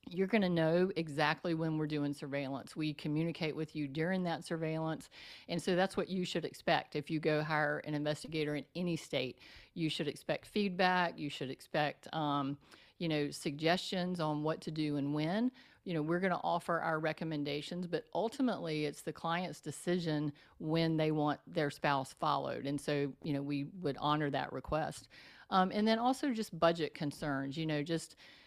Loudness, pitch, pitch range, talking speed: -36 LUFS, 160 Hz, 150-175 Hz, 185 wpm